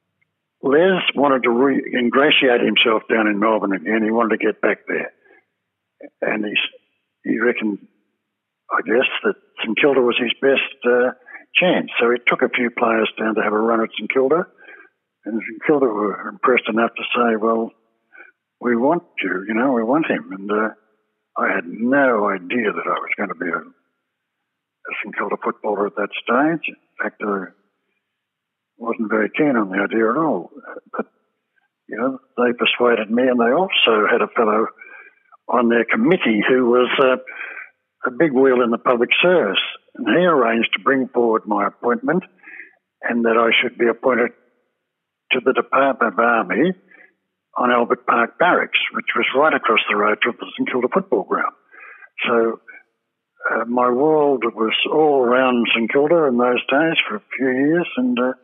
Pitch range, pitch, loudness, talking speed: 110-135 Hz, 120 Hz, -18 LUFS, 175 wpm